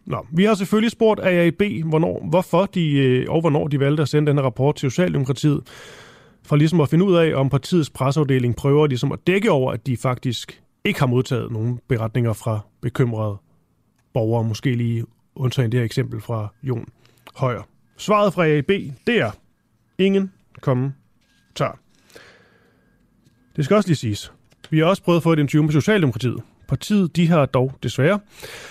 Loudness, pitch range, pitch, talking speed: -20 LUFS, 125-170 Hz, 140 Hz, 165 wpm